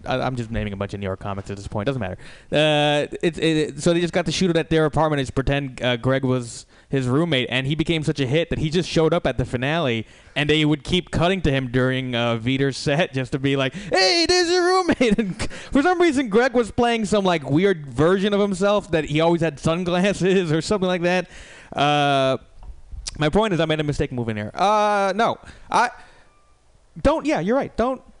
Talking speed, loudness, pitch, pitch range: 230 wpm, -21 LUFS, 155 Hz, 130-190 Hz